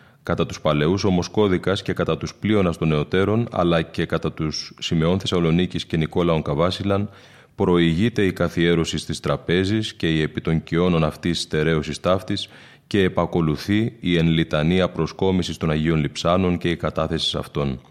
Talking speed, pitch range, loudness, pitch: 145 wpm, 80-95 Hz, -21 LUFS, 85 Hz